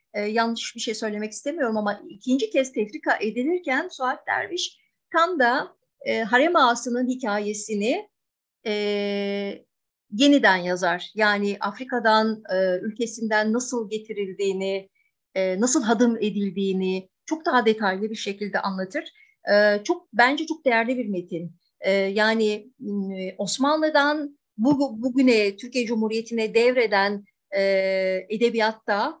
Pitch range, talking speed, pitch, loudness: 200-255 Hz, 115 wpm, 220 Hz, -23 LUFS